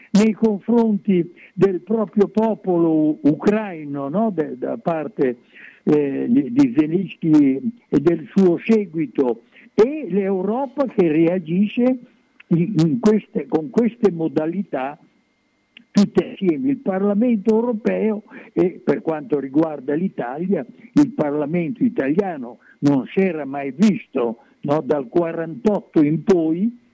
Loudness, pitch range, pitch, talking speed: -20 LUFS, 165-230 Hz, 200 Hz, 110 wpm